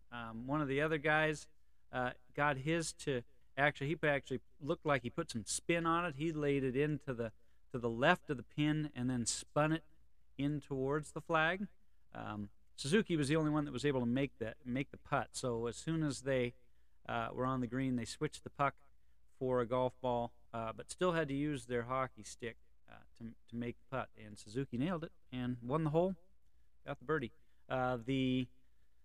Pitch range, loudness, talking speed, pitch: 120-150 Hz, -38 LUFS, 210 wpm, 130 Hz